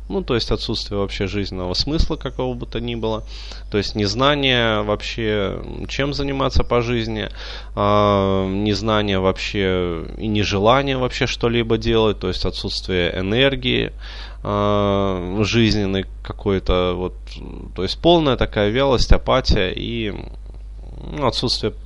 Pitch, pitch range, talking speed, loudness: 105 Hz, 95-120 Hz, 120 wpm, -20 LUFS